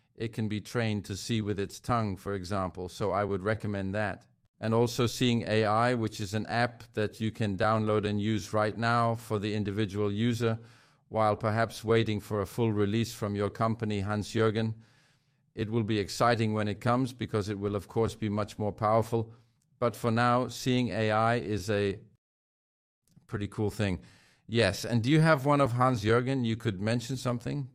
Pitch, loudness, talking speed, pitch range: 110 Hz, -30 LUFS, 190 wpm, 105-120 Hz